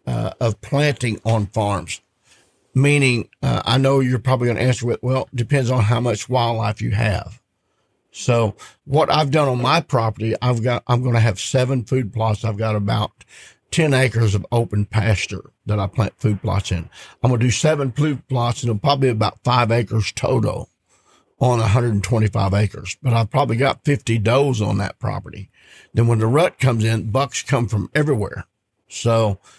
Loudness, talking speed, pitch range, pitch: -19 LUFS, 185 wpm, 110-130 Hz, 115 Hz